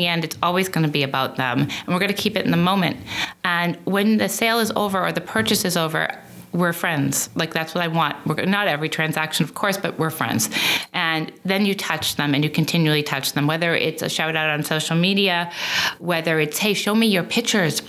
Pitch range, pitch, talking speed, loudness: 155-195 Hz, 170 Hz, 230 wpm, -20 LUFS